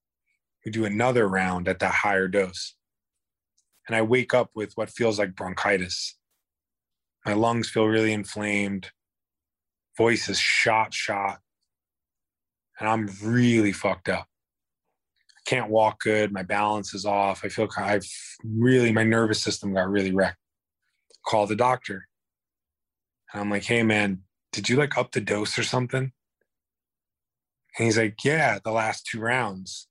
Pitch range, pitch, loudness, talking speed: 95-115 Hz, 105 Hz, -24 LUFS, 150 wpm